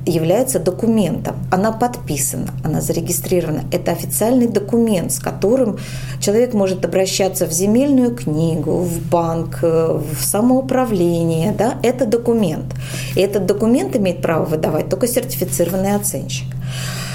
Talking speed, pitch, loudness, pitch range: 115 wpm, 180 Hz, -17 LUFS, 155-220 Hz